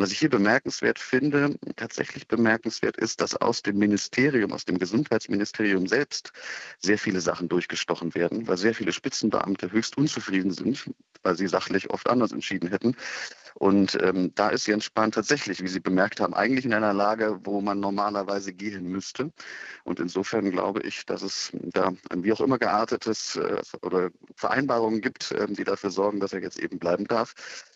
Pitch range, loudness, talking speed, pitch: 95-110 Hz, -26 LUFS, 175 wpm, 100 Hz